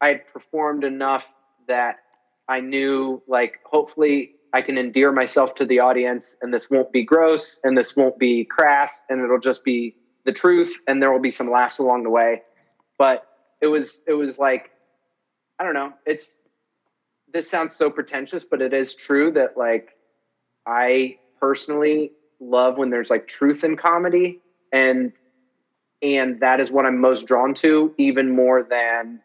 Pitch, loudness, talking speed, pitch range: 130 Hz, -20 LUFS, 170 wpm, 125-145 Hz